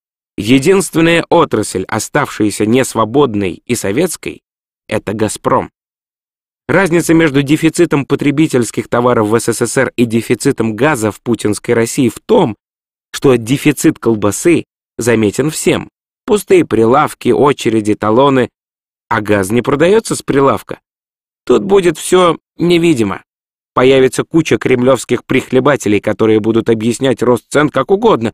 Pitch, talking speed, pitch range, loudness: 125 Hz, 115 wpm, 110-150 Hz, -12 LUFS